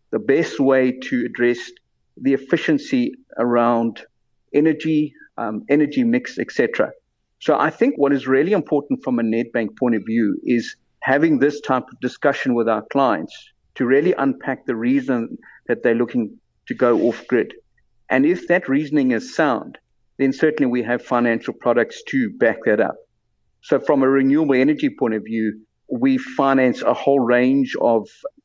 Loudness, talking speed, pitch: -19 LUFS, 165 wpm, 140 Hz